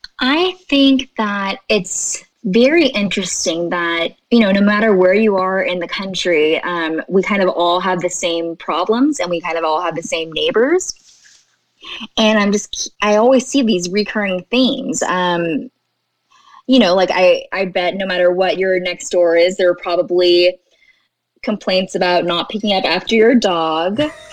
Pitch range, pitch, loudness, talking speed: 175-225 Hz, 190 Hz, -15 LUFS, 170 wpm